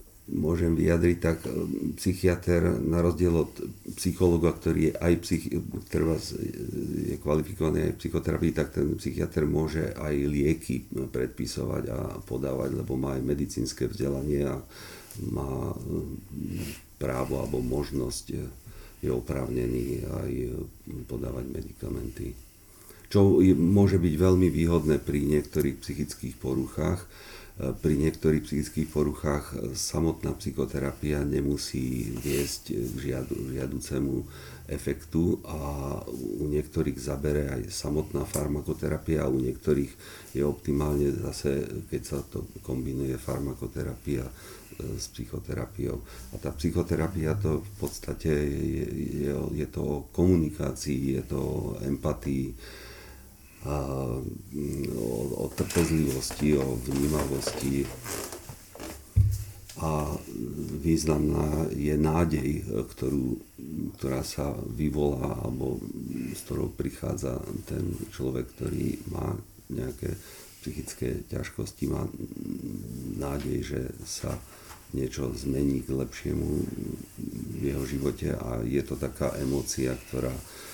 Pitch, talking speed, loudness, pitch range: 75 Hz, 105 wpm, -30 LUFS, 70-80 Hz